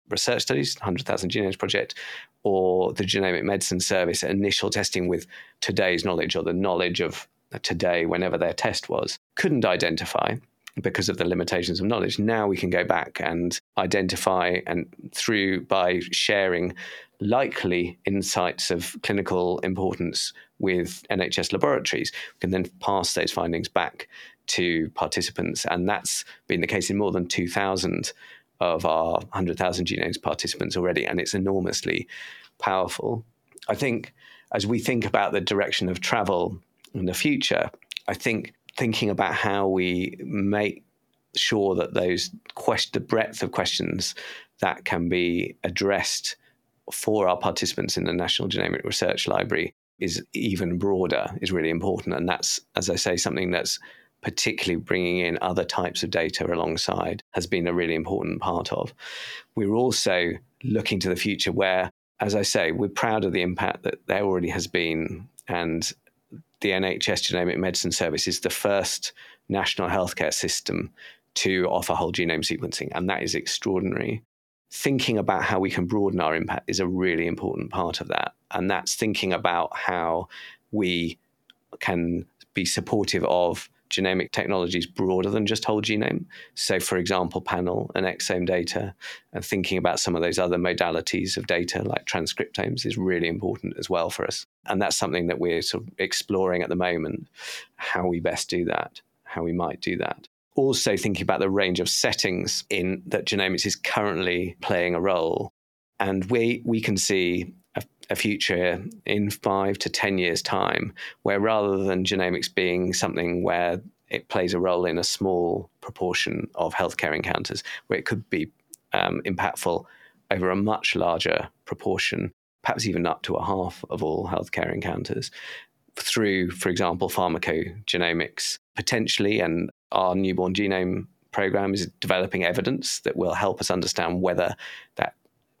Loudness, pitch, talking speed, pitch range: -25 LUFS, 95 Hz, 155 wpm, 90-100 Hz